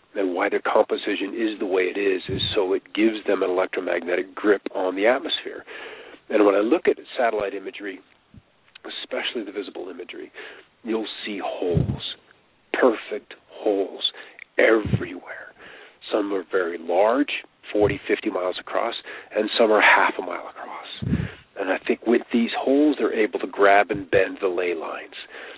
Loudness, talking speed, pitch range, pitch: -23 LUFS, 155 wpm, 330-430 Hz, 390 Hz